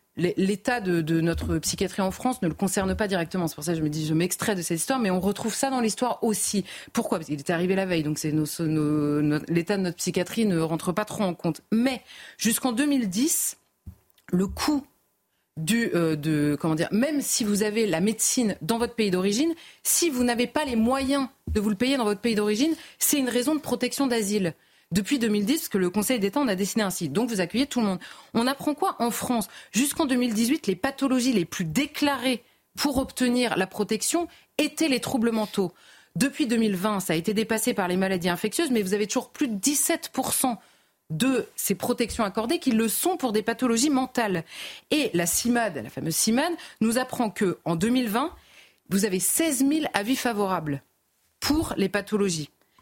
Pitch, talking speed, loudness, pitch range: 220 Hz, 200 wpm, -25 LUFS, 185-255 Hz